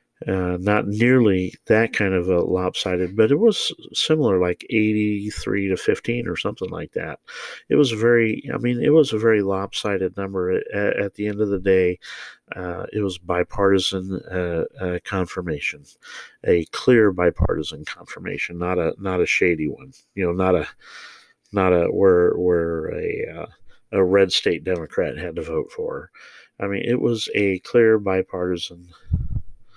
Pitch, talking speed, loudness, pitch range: 105 Hz, 160 wpm, -21 LUFS, 90-125 Hz